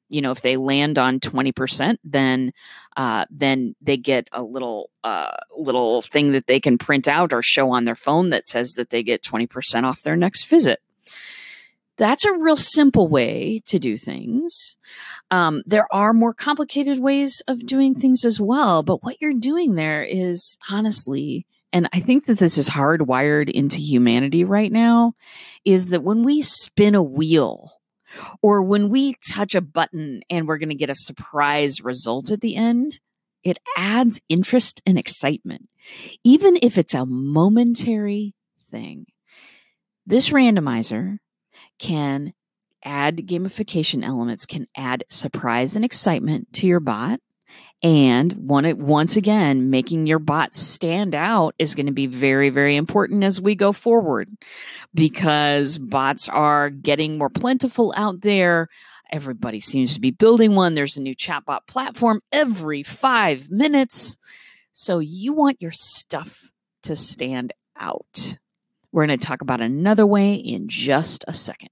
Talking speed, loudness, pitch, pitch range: 155 wpm, -19 LUFS, 175 Hz, 140-225 Hz